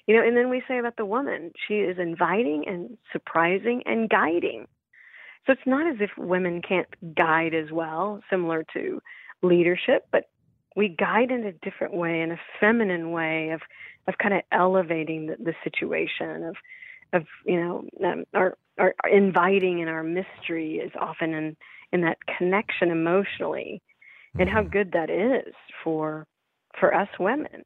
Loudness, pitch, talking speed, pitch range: -25 LUFS, 180 Hz, 165 wpm, 165-215 Hz